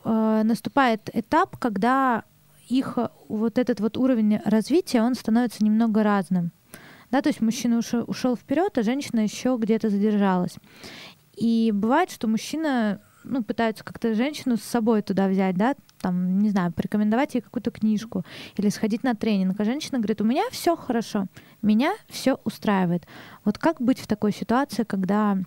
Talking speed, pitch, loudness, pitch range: 155 wpm, 225 Hz, -24 LUFS, 210-250 Hz